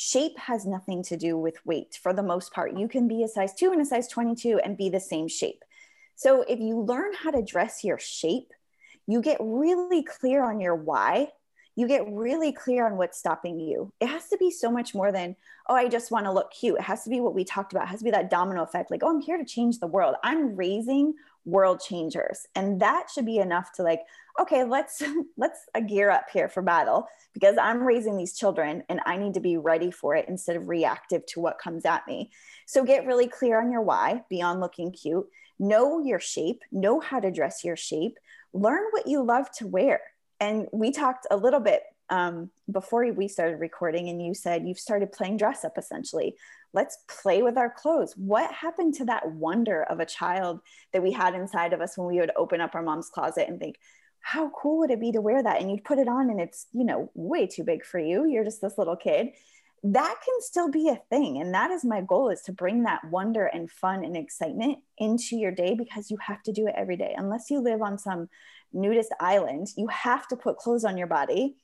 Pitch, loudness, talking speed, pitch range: 225 Hz, -27 LUFS, 230 wpm, 185-280 Hz